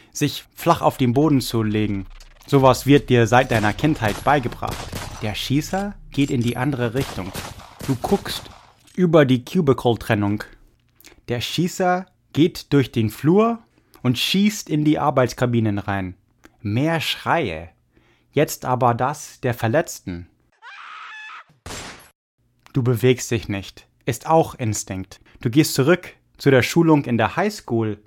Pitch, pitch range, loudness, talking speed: 125 Hz, 110-155 Hz, -20 LUFS, 135 wpm